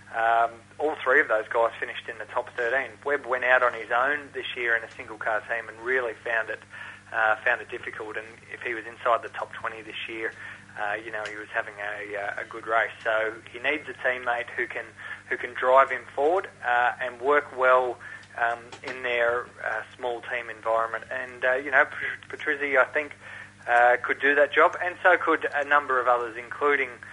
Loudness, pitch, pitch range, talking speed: -26 LUFS, 120 Hz, 115-130 Hz, 210 wpm